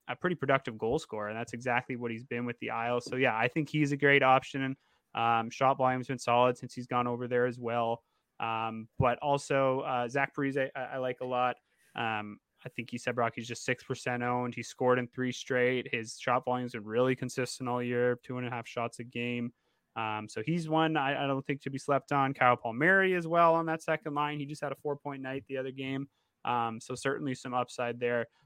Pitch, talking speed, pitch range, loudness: 125 Hz, 235 wpm, 120-135 Hz, -31 LUFS